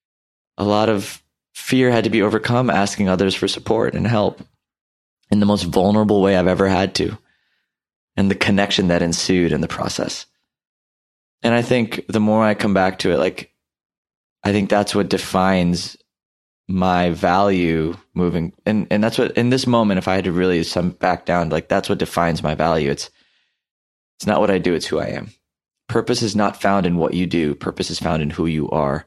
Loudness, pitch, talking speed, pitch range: -18 LUFS, 95 Hz, 200 wpm, 85-105 Hz